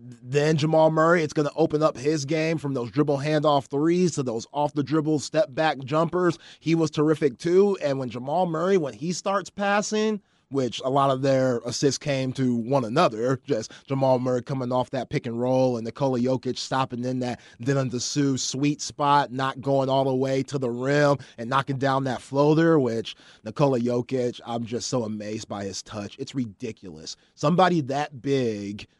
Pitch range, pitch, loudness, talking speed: 125-155 Hz, 135 Hz, -24 LUFS, 190 wpm